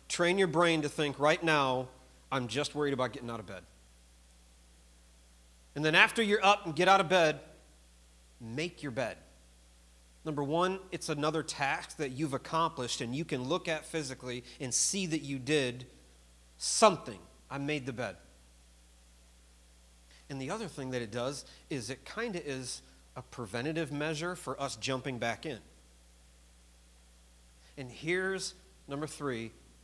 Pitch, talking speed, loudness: 130 Hz, 155 wpm, -32 LUFS